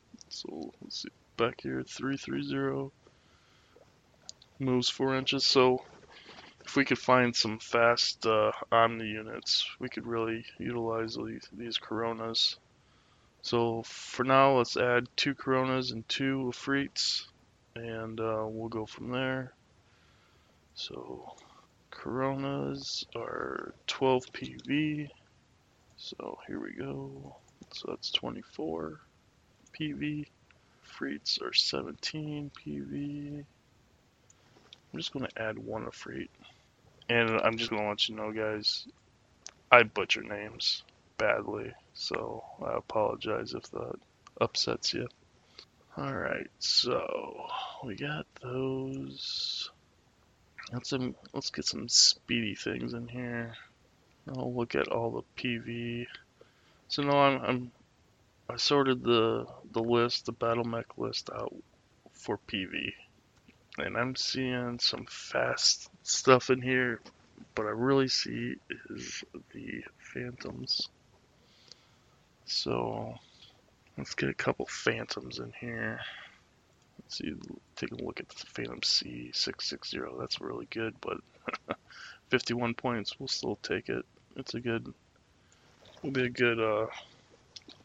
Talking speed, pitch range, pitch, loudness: 120 wpm, 110-130 Hz, 120 Hz, -31 LUFS